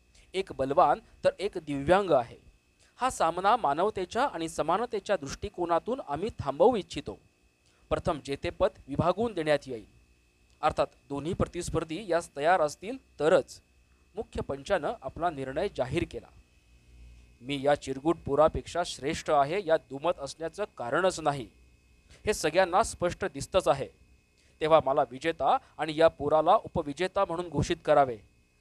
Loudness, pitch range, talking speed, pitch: -29 LUFS, 135-180 Hz, 125 wpm, 155 Hz